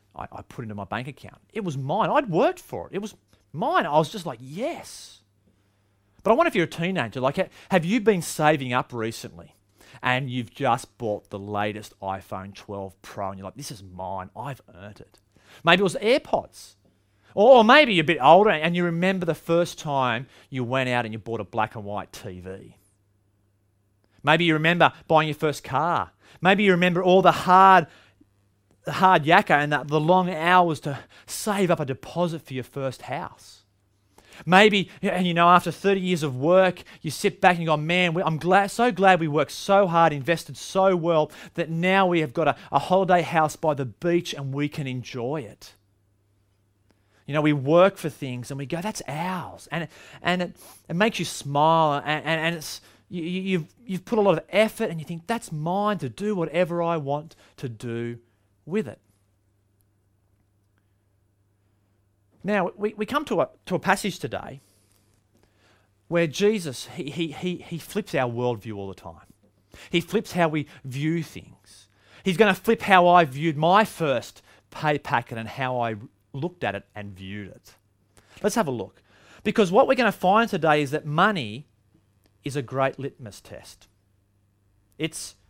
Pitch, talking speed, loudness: 145 Hz, 190 wpm, -23 LUFS